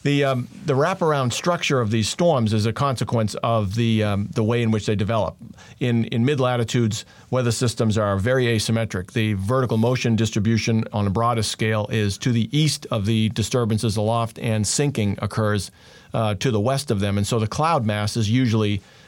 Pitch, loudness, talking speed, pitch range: 115 Hz, -22 LUFS, 190 wpm, 110-125 Hz